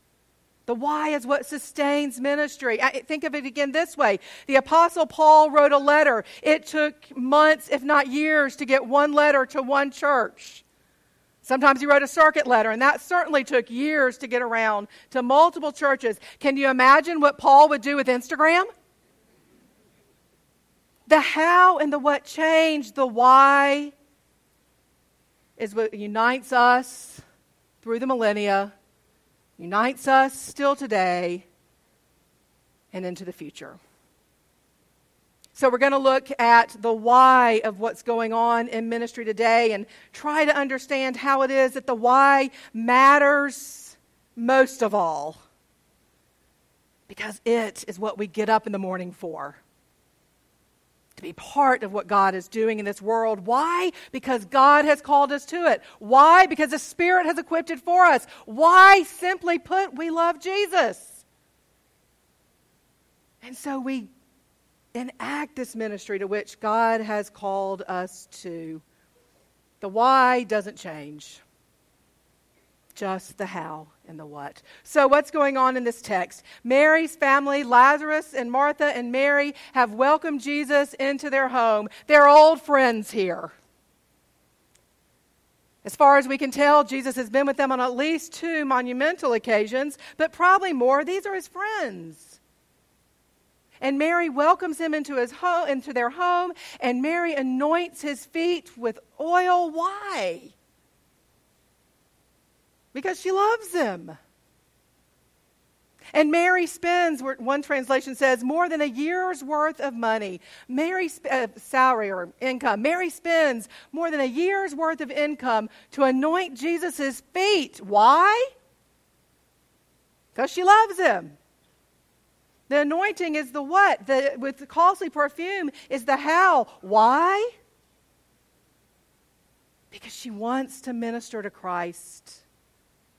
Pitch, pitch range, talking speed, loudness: 275 Hz, 235-310 Hz, 135 wpm, -21 LUFS